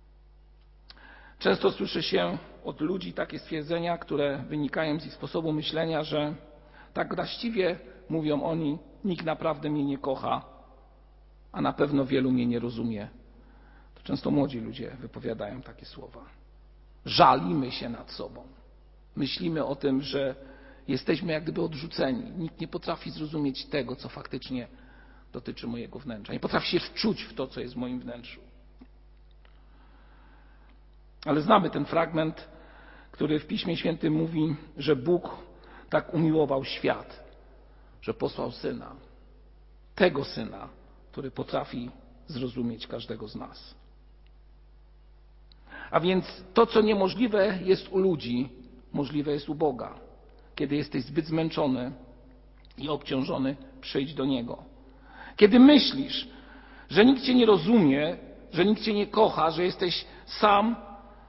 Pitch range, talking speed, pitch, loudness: 125-170 Hz, 125 wpm, 150 Hz, -27 LUFS